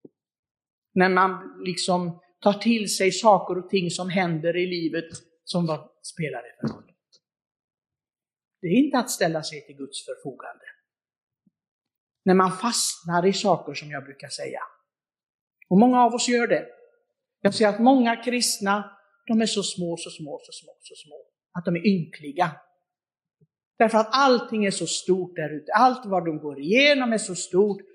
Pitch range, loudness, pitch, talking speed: 170-230 Hz, -23 LUFS, 190 Hz, 165 wpm